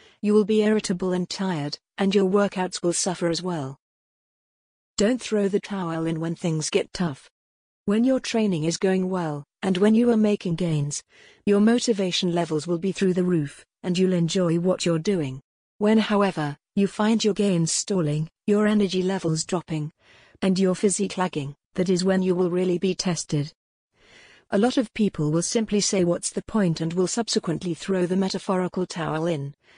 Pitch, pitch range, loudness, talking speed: 185 Hz, 165-205 Hz, -24 LUFS, 180 wpm